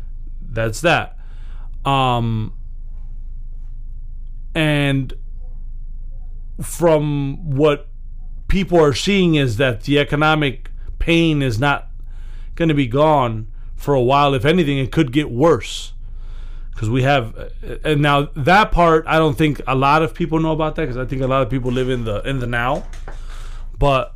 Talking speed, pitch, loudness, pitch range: 150 wpm, 135 Hz, -17 LUFS, 115-155 Hz